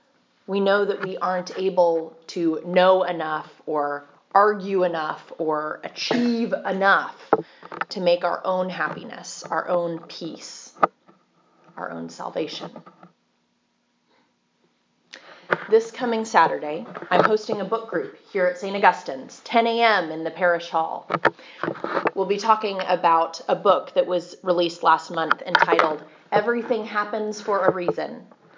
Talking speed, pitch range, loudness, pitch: 130 wpm, 170-215 Hz, -23 LUFS, 185 Hz